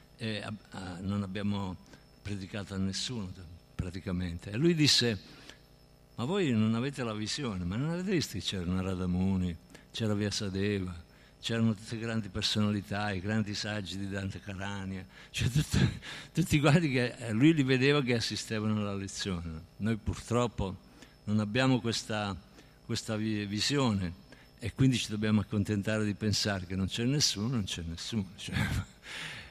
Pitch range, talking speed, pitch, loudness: 95-115 Hz, 150 wpm, 105 Hz, -32 LUFS